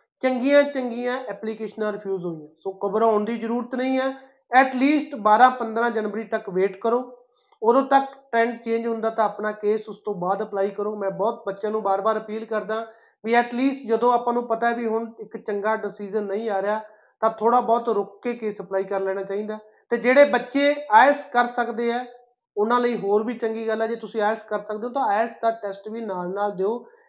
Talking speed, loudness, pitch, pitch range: 200 wpm, -23 LUFS, 225 Hz, 210-245 Hz